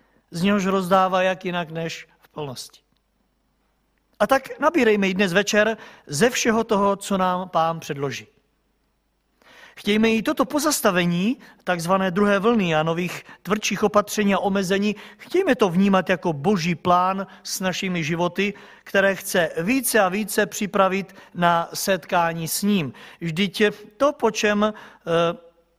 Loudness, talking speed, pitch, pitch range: -21 LUFS, 135 wpm, 195 Hz, 175-215 Hz